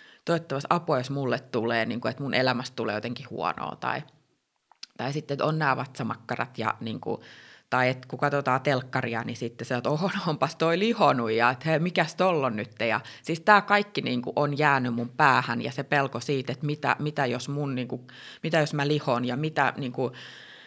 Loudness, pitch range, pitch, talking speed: -27 LUFS, 125-150 Hz, 135 Hz, 205 wpm